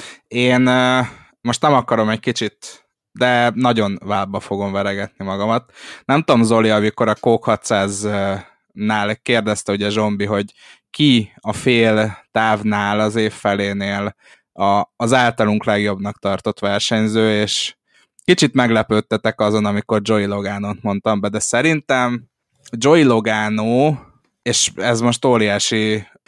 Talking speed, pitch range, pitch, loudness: 125 wpm, 100-120 Hz, 110 Hz, -17 LUFS